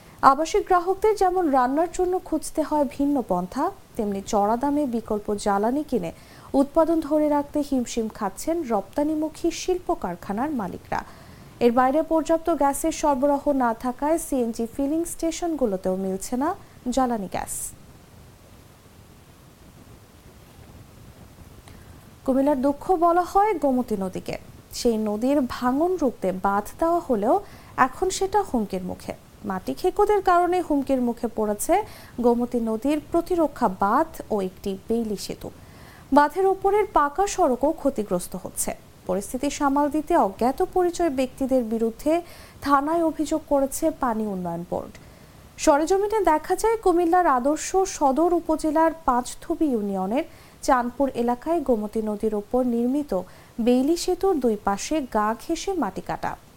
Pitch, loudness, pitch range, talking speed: 285 Hz, -24 LUFS, 235-330 Hz, 120 wpm